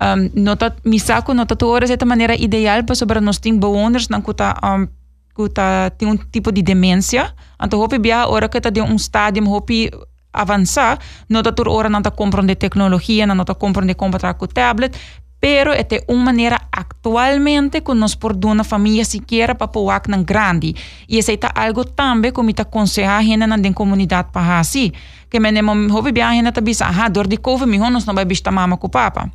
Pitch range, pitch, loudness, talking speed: 200-235 Hz, 215 Hz, -15 LUFS, 190 wpm